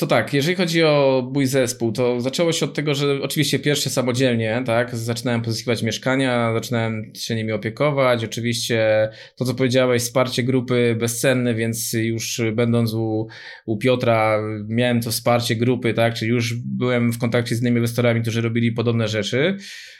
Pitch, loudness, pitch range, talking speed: 120 Hz, -20 LUFS, 115-130 Hz, 160 wpm